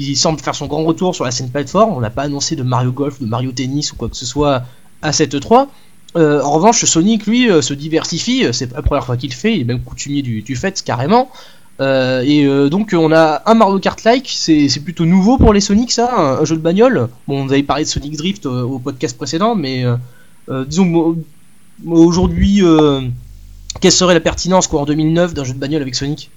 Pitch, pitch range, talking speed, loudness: 155 Hz, 140-180 Hz, 230 wpm, -14 LUFS